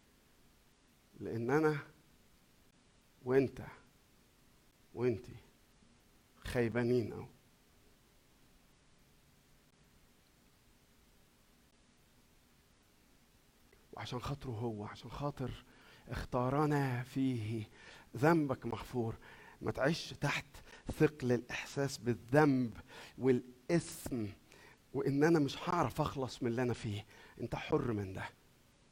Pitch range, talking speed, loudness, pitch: 115-135 Hz, 75 wpm, -36 LUFS, 125 Hz